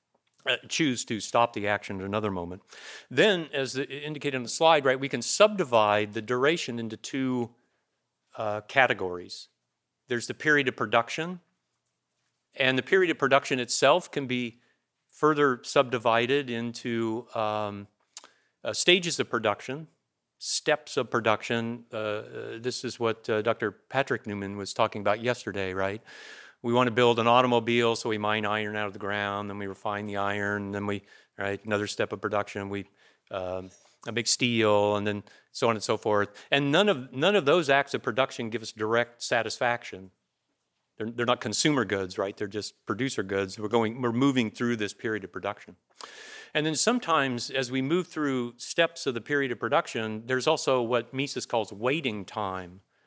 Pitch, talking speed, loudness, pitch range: 120 Hz, 175 wpm, -27 LUFS, 105-130 Hz